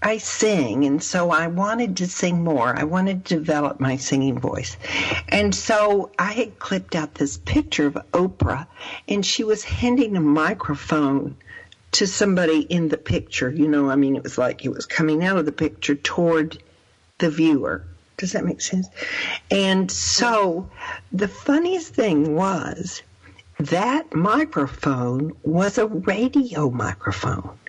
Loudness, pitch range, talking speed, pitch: -21 LUFS, 140-195 Hz, 150 wpm, 160 Hz